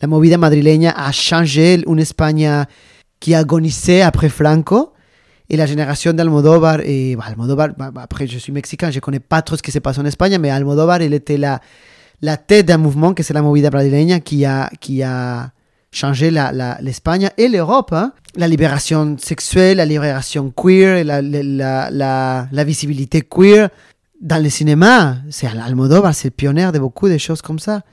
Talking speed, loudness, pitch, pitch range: 175 wpm, -14 LUFS, 150 Hz, 140-165 Hz